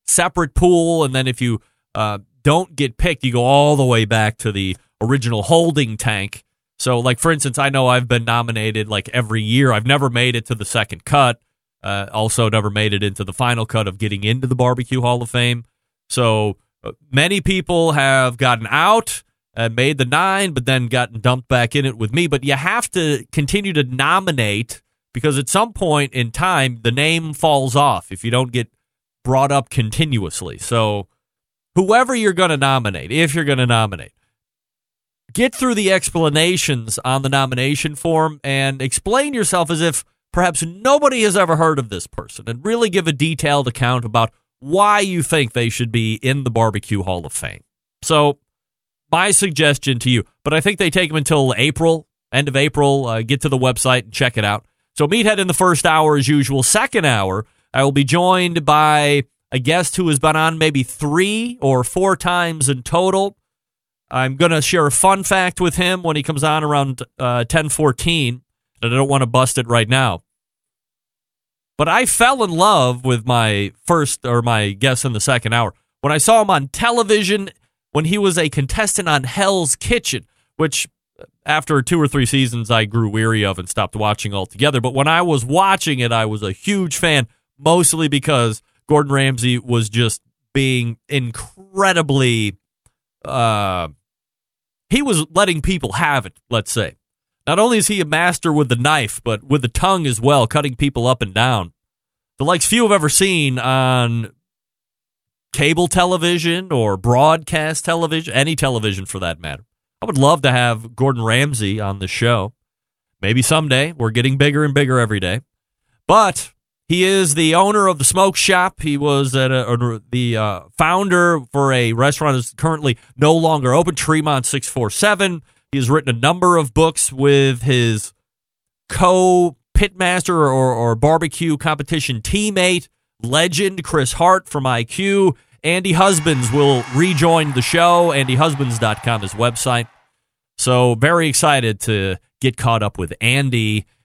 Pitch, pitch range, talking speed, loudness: 135 Hz, 120-165 Hz, 175 wpm, -16 LUFS